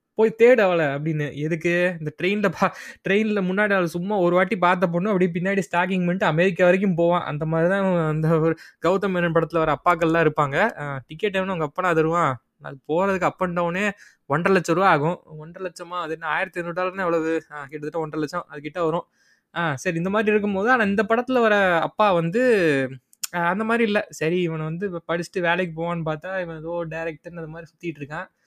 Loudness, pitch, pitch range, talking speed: -22 LUFS, 175 Hz, 160-190 Hz, 190 wpm